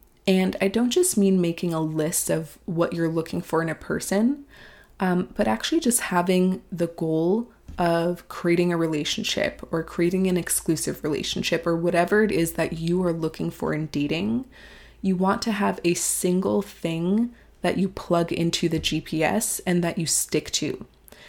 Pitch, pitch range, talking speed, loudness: 175 Hz, 165-195 Hz, 170 wpm, -24 LUFS